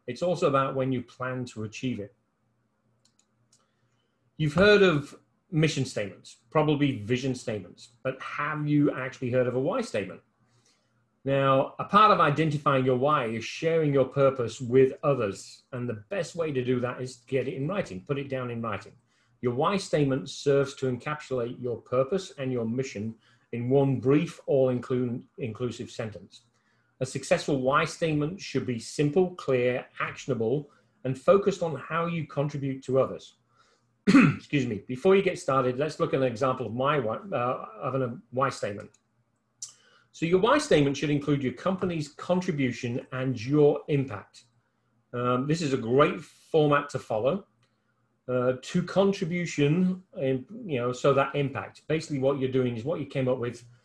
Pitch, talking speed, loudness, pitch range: 130 Hz, 165 wpm, -27 LUFS, 120-150 Hz